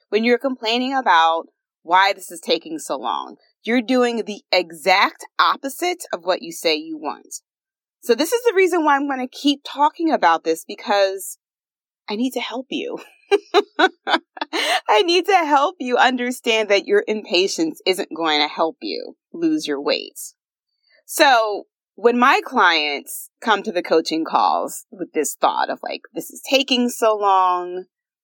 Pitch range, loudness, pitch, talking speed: 200-335 Hz, -19 LUFS, 255 Hz, 160 wpm